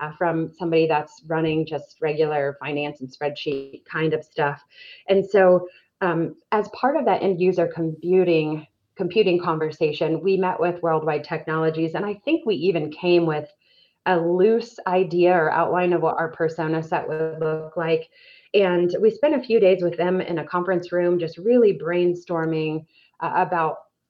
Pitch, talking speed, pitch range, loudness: 170 Hz, 165 wpm, 160-185 Hz, -22 LUFS